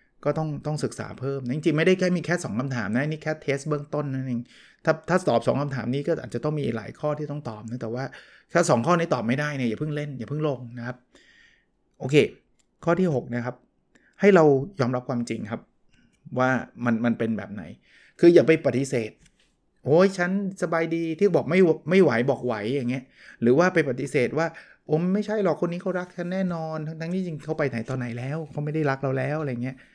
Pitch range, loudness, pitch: 125-165 Hz, -25 LUFS, 150 Hz